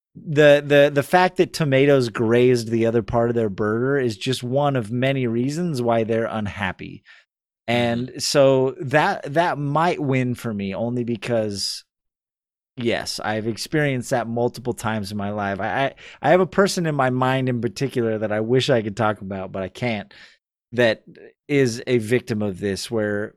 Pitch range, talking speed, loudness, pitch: 110-135 Hz, 175 wpm, -21 LUFS, 120 Hz